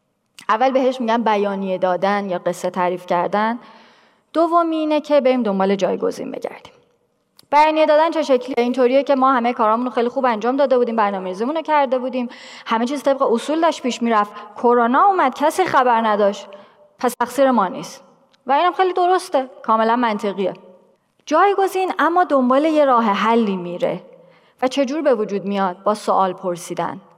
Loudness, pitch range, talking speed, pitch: -18 LUFS, 210-285 Hz, 155 wpm, 245 Hz